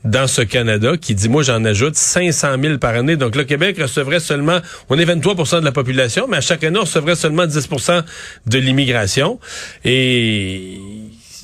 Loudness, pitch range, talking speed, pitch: -15 LUFS, 120-170 Hz, 180 wpm, 145 Hz